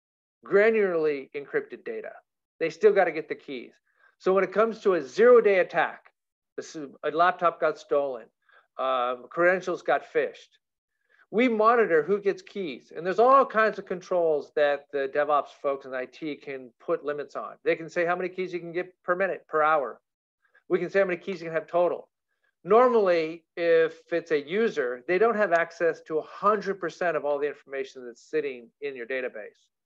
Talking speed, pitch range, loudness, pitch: 185 wpm, 155-230 Hz, -26 LUFS, 180 Hz